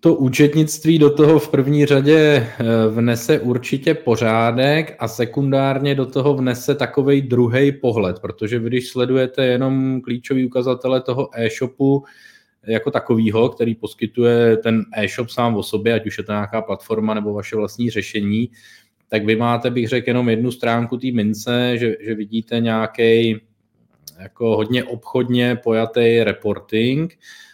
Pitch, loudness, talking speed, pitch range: 120 Hz, -18 LUFS, 140 wpm, 110-135 Hz